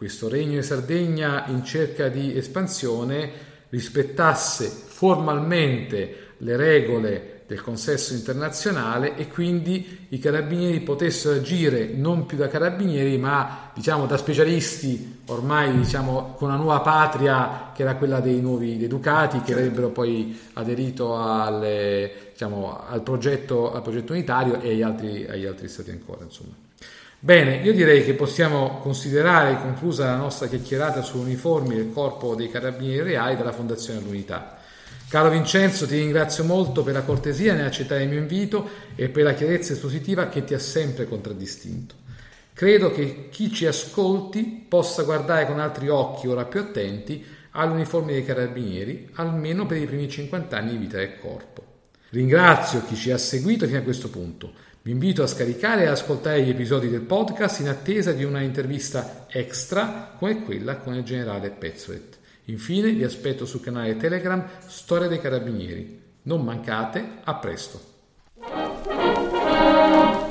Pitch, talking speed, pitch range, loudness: 140 Hz, 145 wpm, 120-160 Hz, -23 LUFS